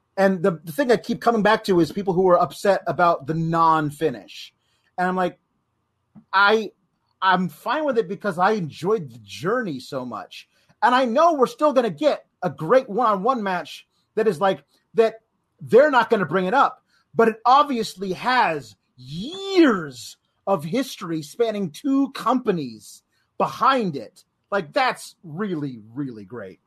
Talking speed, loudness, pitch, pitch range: 160 wpm, -21 LUFS, 195 Hz, 165-230 Hz